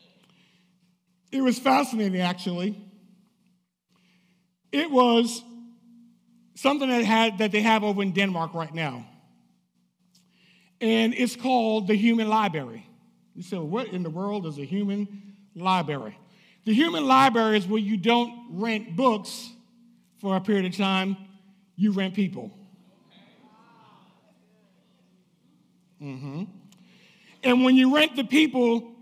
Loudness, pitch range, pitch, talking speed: -24 LUFS, 185-230 Hz, 200 Hz, 120 wpm